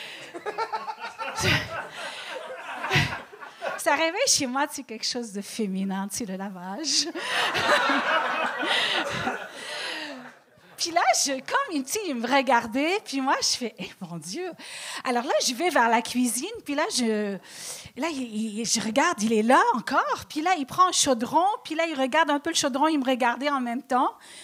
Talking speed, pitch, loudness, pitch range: 155 wpm, 275 Hz, -25 LUFS, 230-325 Hz